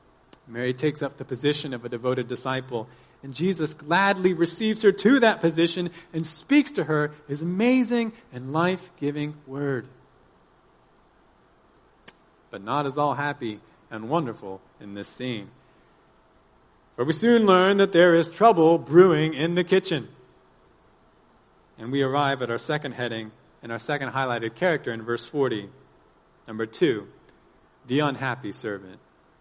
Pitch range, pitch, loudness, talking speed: 125-170 Hz, 145 Hz, -24 LUFS, 140 wpm